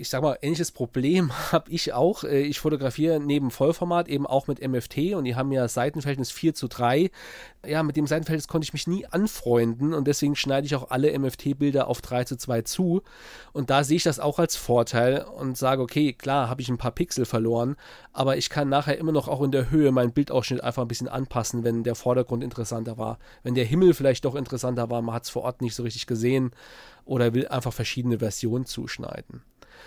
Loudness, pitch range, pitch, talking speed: -25 LUFS, 125-150 Hz, 130 Hz, 215 wpm